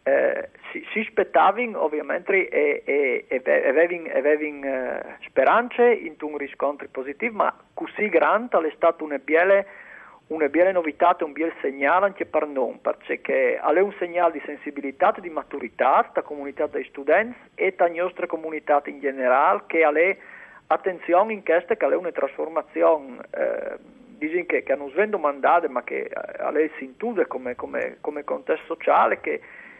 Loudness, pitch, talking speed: -23 LUFS, 175 Hz, 155 wpm